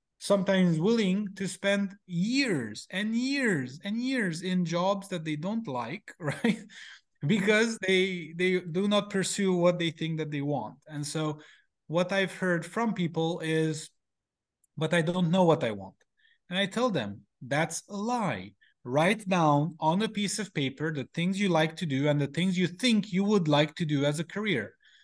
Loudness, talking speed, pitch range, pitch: -28 LUFS, 180 wpm, 155-200 Hz, 180 Hz